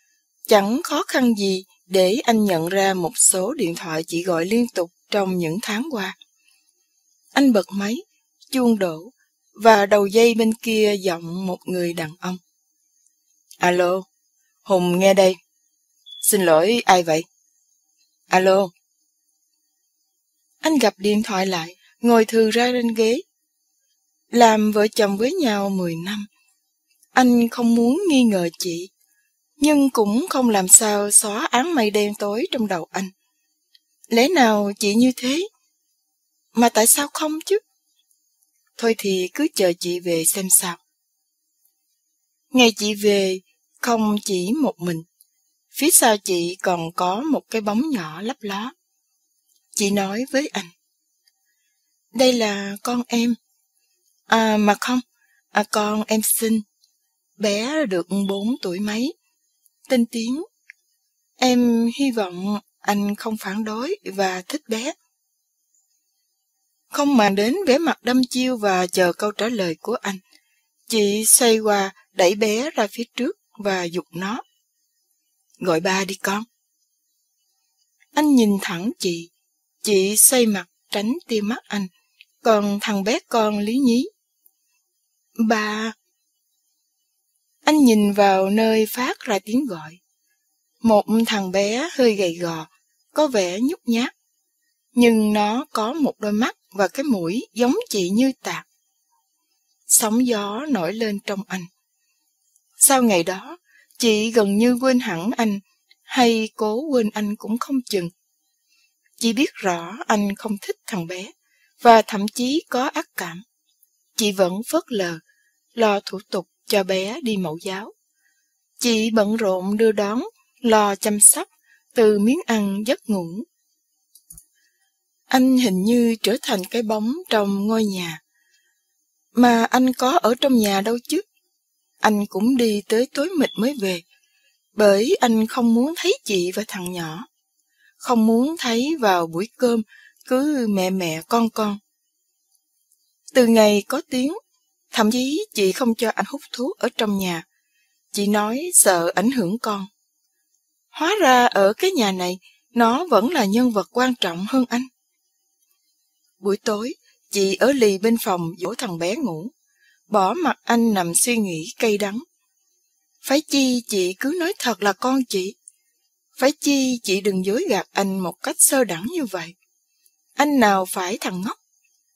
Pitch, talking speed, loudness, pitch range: 225 Hz, 145 wpm, -20 LUFS, 195-280 Hz